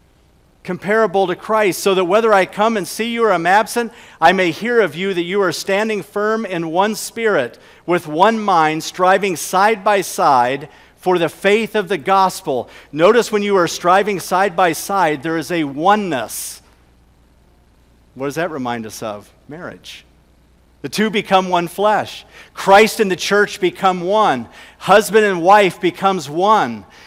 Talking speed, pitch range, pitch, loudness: 165 wpm, 160-205 Hz, 190 Hz, -16 LUFS